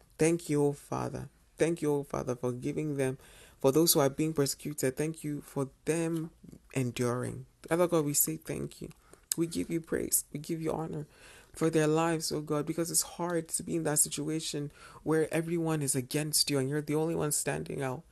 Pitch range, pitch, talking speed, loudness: 140-160 Hz, 150 Hz, 210 wpm, -31 LUFS